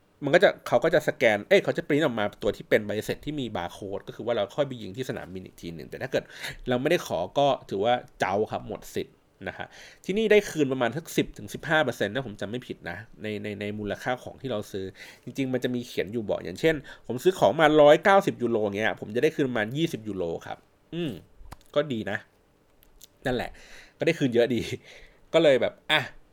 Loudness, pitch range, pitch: -26 LUFS, 105-150 Hz, 125 Hz